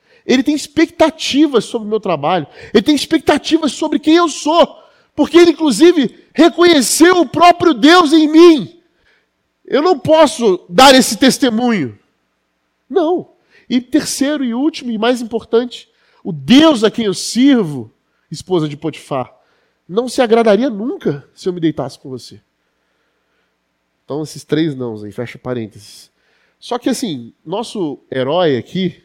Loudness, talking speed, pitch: -13 LUFS, 145 wpm, 245 Hz